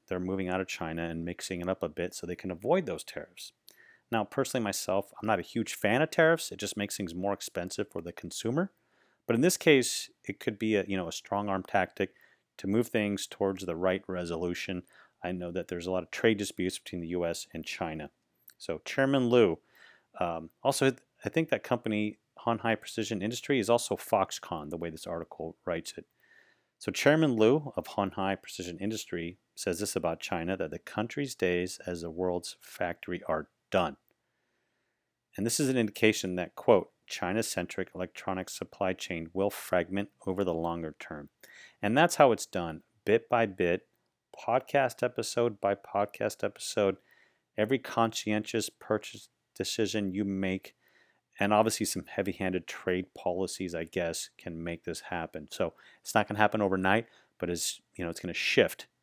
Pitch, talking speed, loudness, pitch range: 100 Hz, 180 wpm, -31 LUFS, 90-110 Hz